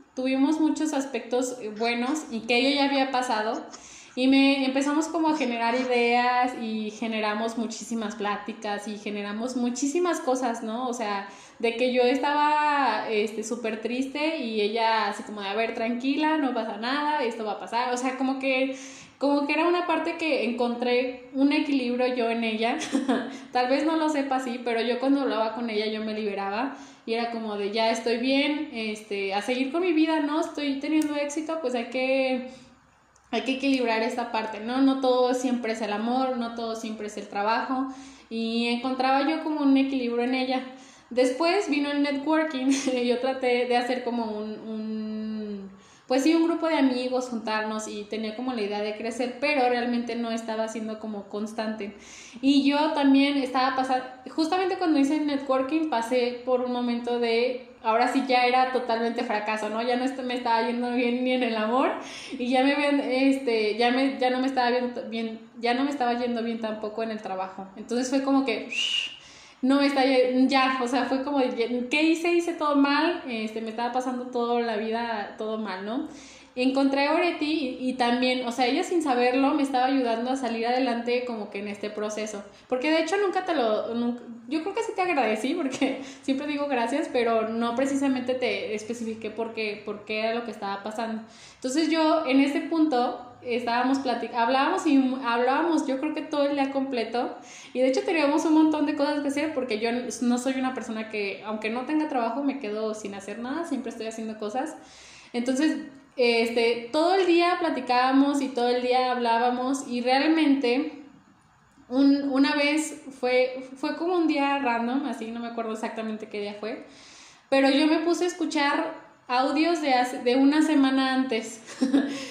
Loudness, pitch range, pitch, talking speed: -26 LUFS, 230-275 Hz, 250 Hz, 185 wpm